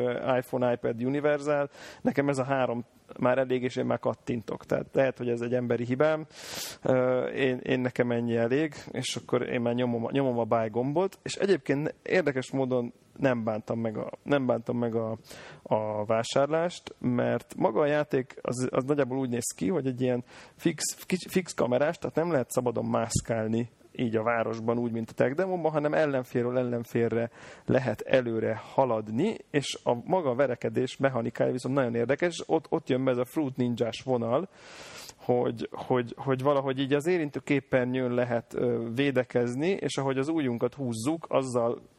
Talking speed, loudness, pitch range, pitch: 165 wpm, -29 LUFS, 120-140 Hz, 125 Hz